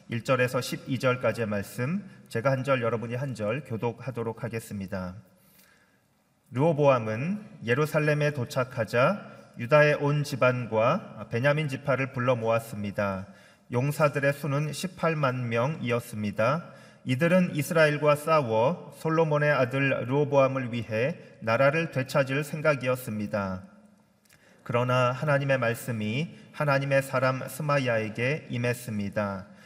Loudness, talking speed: -27 LUFS, 280 characters per minute